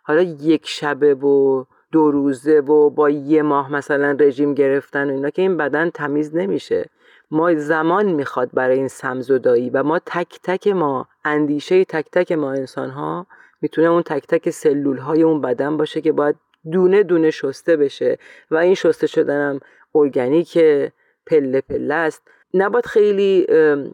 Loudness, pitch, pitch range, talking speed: -18 LUFS, 155 Hz, 145-180 Hz, 160 wpm